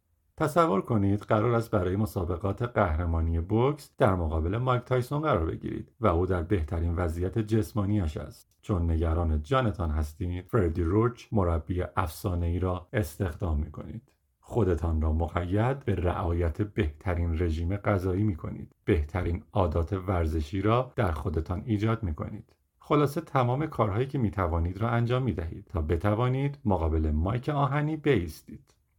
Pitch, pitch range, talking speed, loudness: 100 Hz, 85-115 Hz, 145 wpm, -28 LUFS